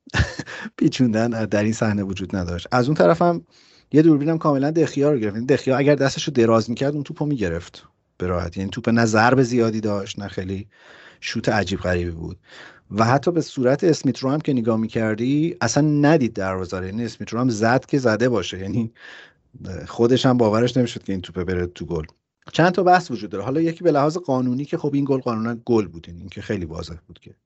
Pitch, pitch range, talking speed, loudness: 115 Hz, 100-140 Hz, 210 wpm, -21 LUFS